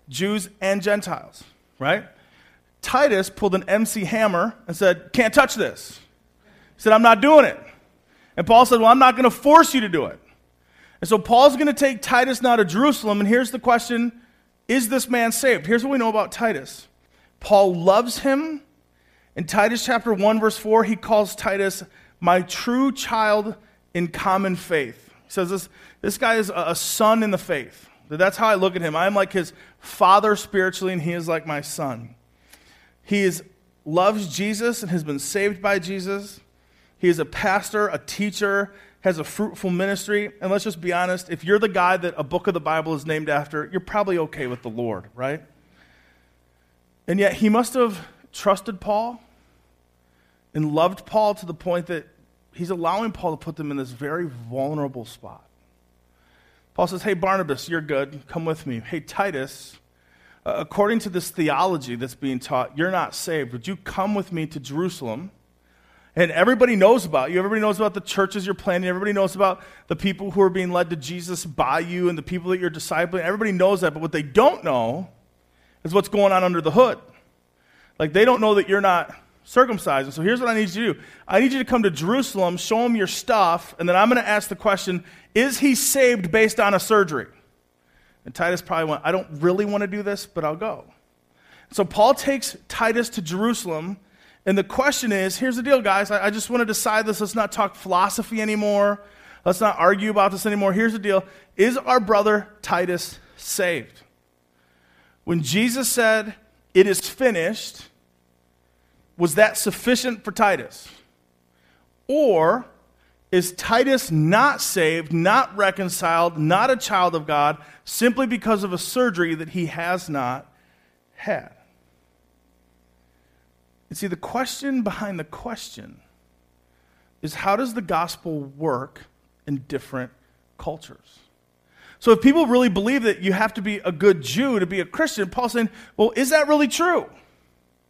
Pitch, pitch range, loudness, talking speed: 185 Hz, 145-215 Hz, -21 LUFS, 180 wpm